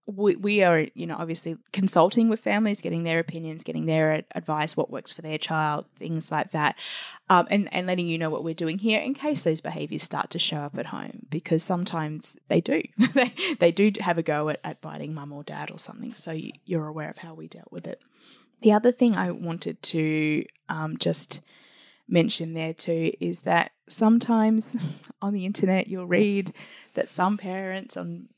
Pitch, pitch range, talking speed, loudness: 175 Hz, 160-210 Hz, 200 wpm, -25 LUFS